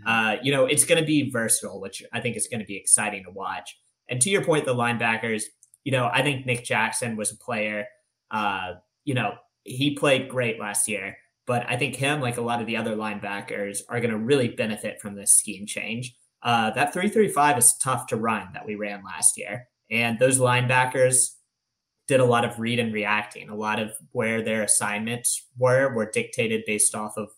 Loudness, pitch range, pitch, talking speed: -23 LUFS, 110-130 Hz, 120 Hz, 210 wpm